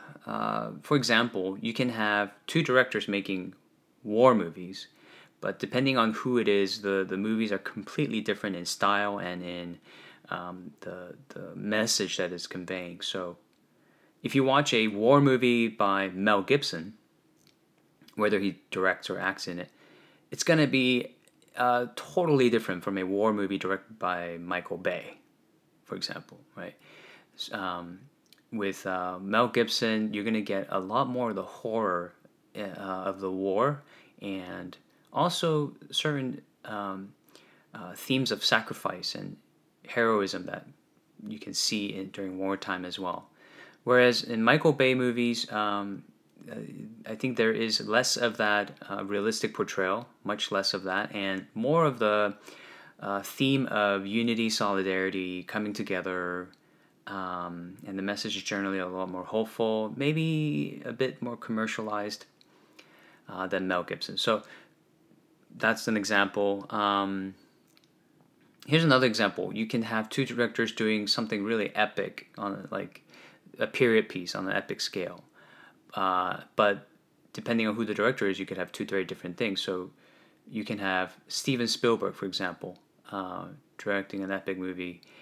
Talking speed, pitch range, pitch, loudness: 150 wpm, 95-120 Hz, 105 Hz, -29 LUFS